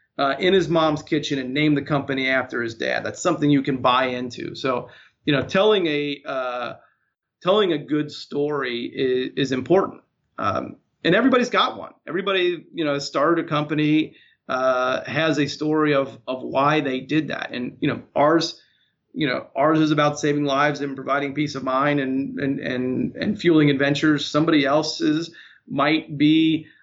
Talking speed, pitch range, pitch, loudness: 175 wpm, 135-155 Hz, 145 Hz, -22 LUFS